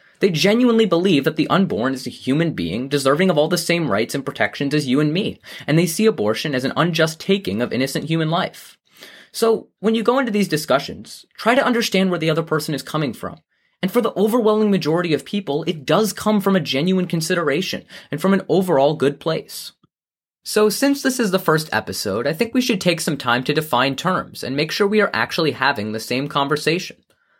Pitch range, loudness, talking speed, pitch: 150-210 Hz, -19 LUFS, 215 wpm, 170 Hz